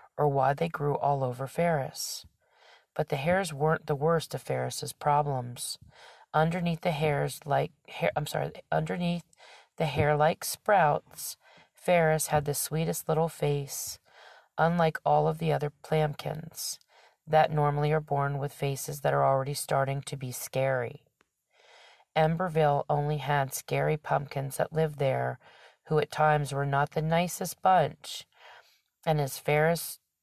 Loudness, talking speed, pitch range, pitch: -29 LUFS, 145 wpm, 140-160 Hz, 150 Hz